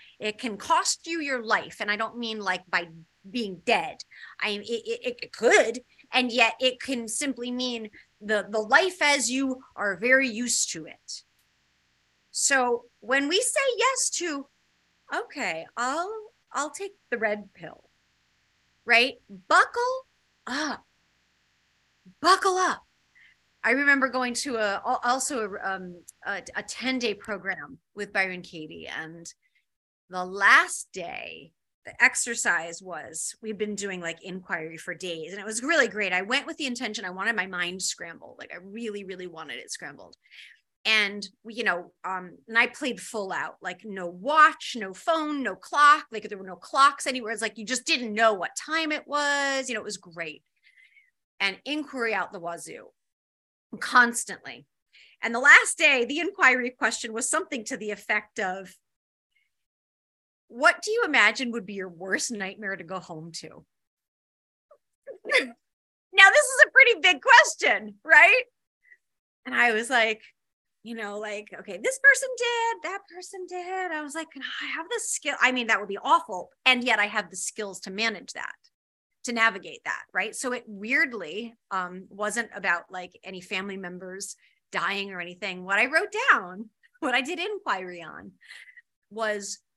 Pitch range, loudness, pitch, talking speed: 195-290 Hz, -24 LUFS, 230 Hz, 165 wpm